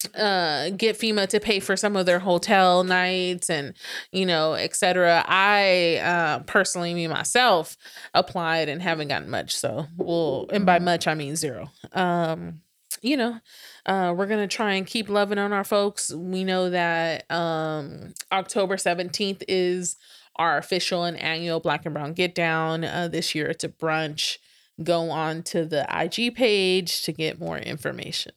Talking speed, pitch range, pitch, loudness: 165 wpm, 165-190 Hz, 175 Hz, -24 LUFS